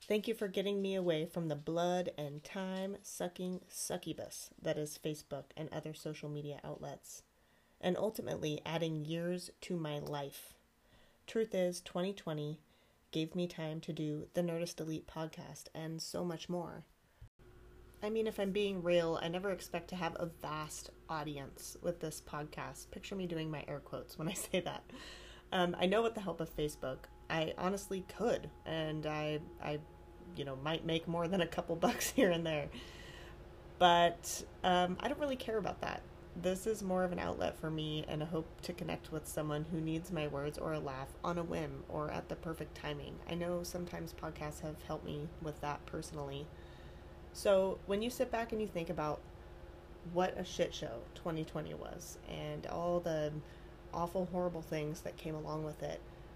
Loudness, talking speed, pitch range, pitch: -39 LUFS, 180 wpm, 150-180 Hz, 165 Hz